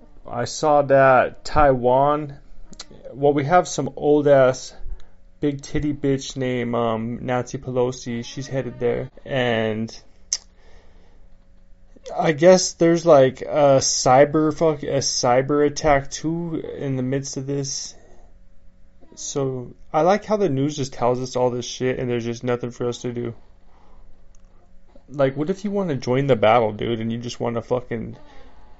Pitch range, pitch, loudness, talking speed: 115-145 Hz, 125 Hz, -20 LUFS, 150 wpm